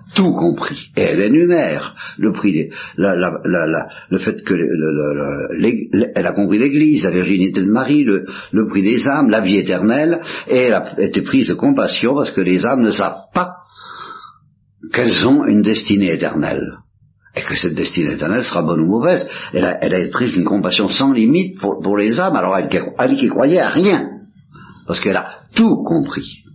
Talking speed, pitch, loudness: 195 wpm, 110 Hz, -16 LUFS